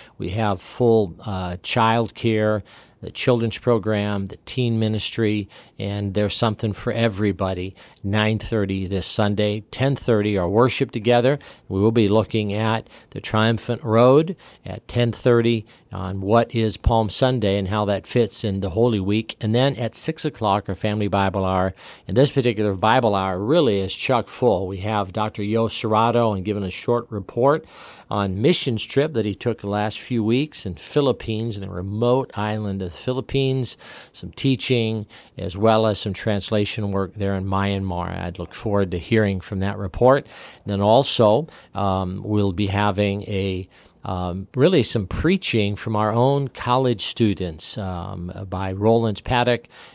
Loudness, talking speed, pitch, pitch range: -21 LUFS, 160 wpm, 105 Hz, 100-115 Hz